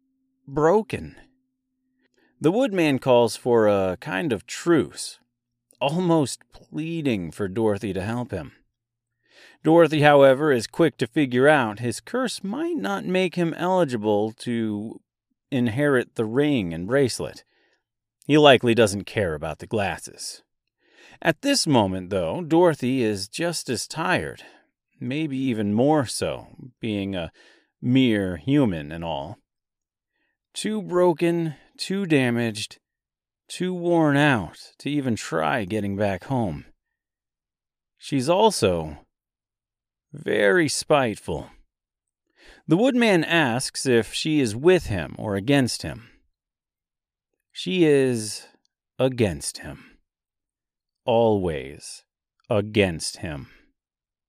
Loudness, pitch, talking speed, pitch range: -22 LUFS, 130 Hz, 105 wpm, 110-165 Hz